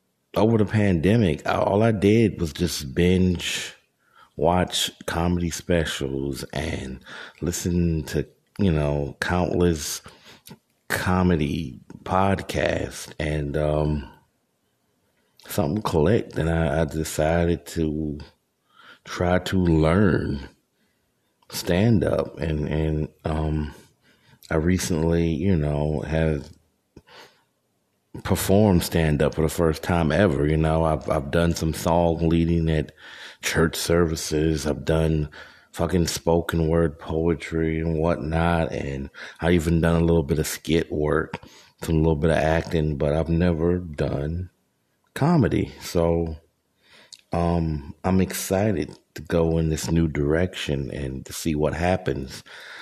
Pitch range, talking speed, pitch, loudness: 75-85 Hz, 120 wpm, 80 Hz, -23 LUFS